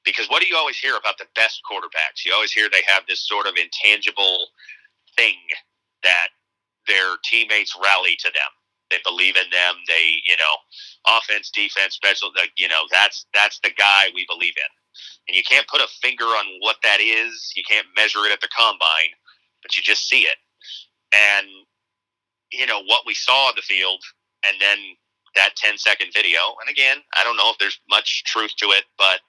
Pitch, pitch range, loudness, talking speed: 100 Hz, 95-100 Hz, -17 LUFS, 195 wpm